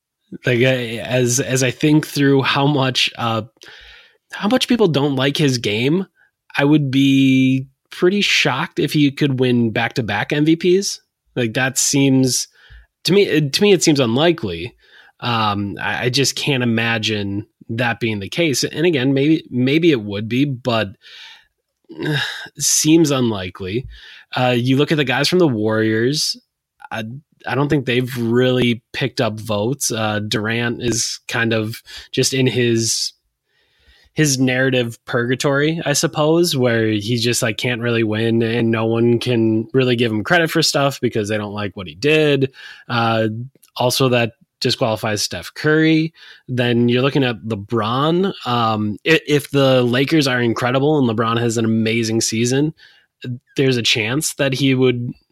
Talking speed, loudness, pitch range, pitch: 155 wpm, -17 LUFS, 115-145 Hz, 125 Hz